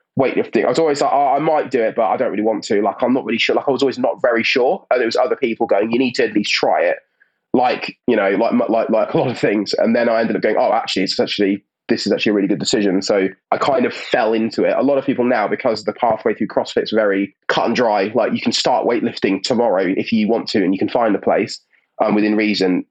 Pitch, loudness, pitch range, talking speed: 105 Hz, -17 LUFS, 100-110 Hz, 290 wpm